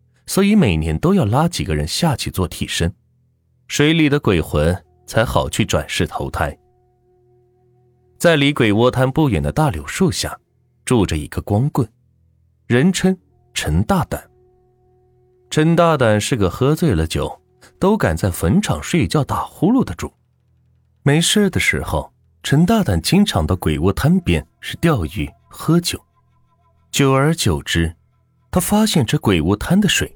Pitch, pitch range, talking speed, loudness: 120 Hz, 95-150 Hz, 205 characters per minute, -17 LUFS